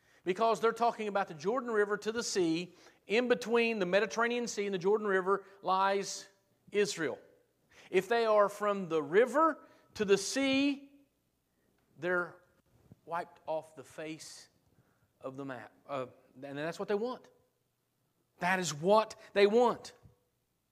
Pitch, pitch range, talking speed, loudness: 200 Hz, 180-235 Hz, 140 wpm, -32 LUFS